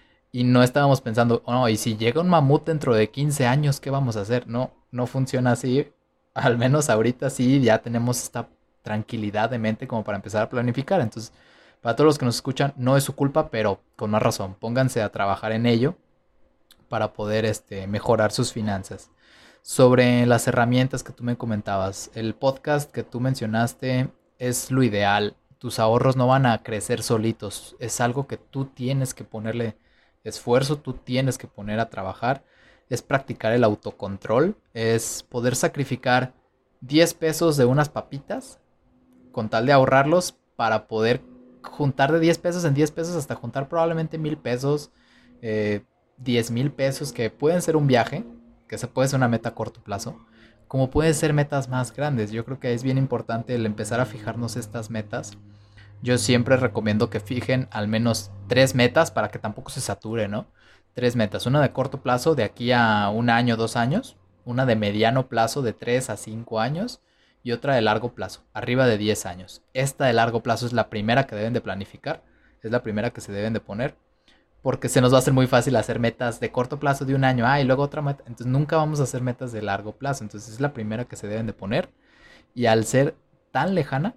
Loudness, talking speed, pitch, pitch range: -23 LUFS, 195 wpm, 120 Hz, 110-135 Hz